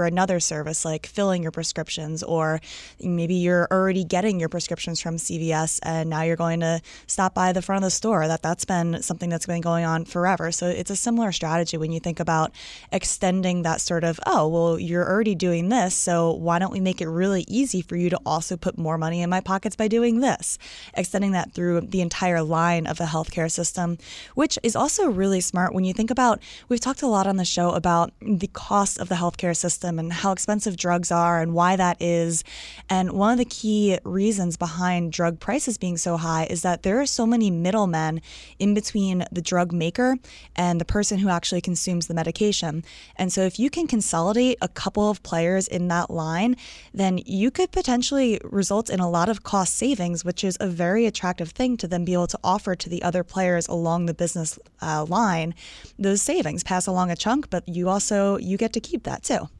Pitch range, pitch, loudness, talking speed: 170-200 Hz, 180 Hz, -23 LUFS, 210 wpm